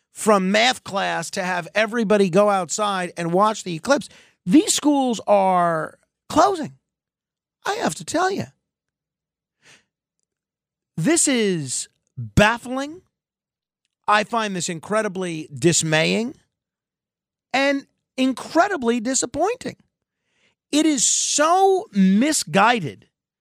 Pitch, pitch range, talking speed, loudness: 210 Hz, 180-270 Hz, 90 wpm, -20 LUFS